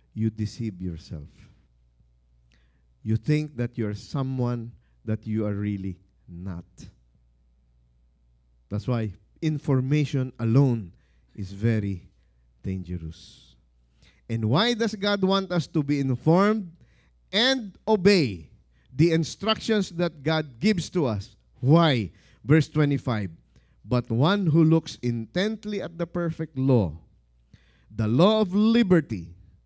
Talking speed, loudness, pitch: 110 wpm, -25 LUFS, 115 Hz